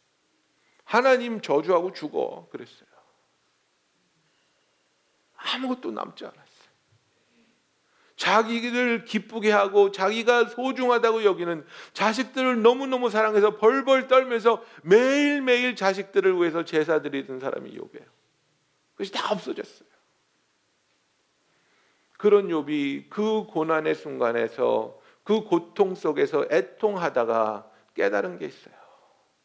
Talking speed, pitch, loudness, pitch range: 245 characters per minute, 215 Hz, -24 LUFS, 175-245 Hz